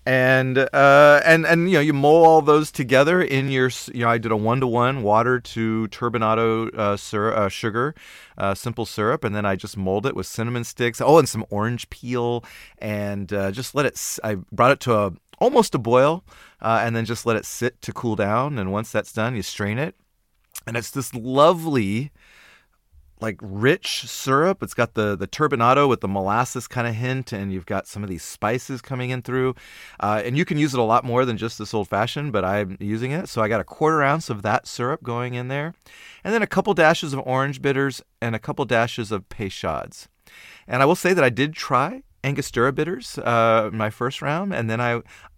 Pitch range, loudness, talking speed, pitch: 110-140 Hz, -21 LUFS, 215 wpm, 120 Hz